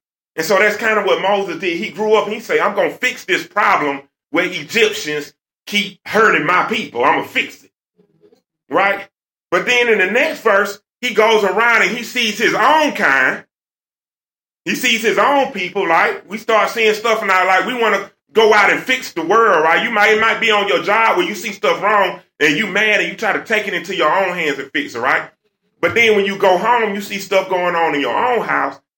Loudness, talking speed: -15 LUFS, 235 wpm